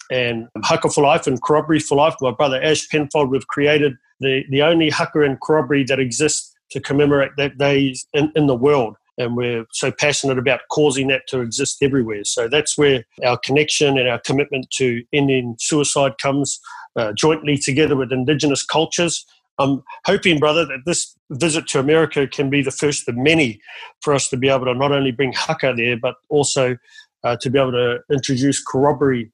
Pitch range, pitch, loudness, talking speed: 130-150 Hz, 140 Hz, -18 LUFS, 190 wpm